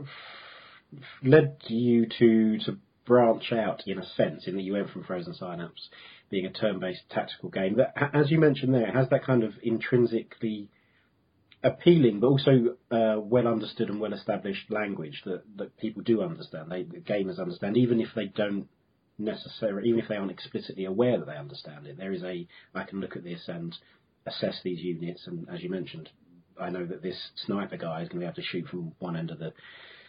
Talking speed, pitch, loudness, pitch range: 195 wpm, 110 Hz, -28 LUFS, 95-120 Hz